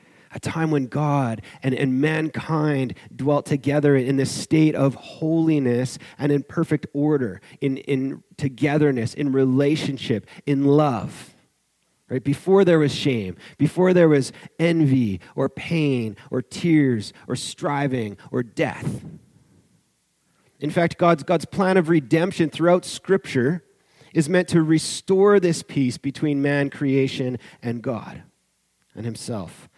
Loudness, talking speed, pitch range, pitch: -22 LUFS, 130 wpm, 130-160 Hz, 145 Hz